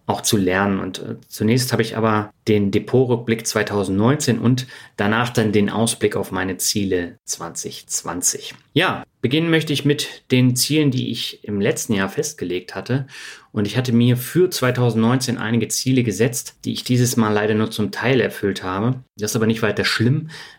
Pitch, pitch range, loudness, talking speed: 115 Hz, 105-125 Hz, -20 LUFS, 170 wpm